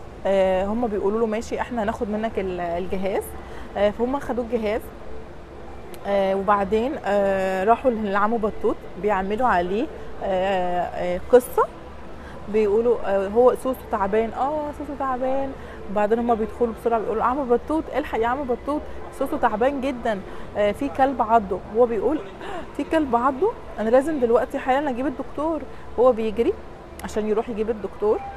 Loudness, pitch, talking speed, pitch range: -23 LUFS, 235 Hz, 140 wpm, 200-265 Hz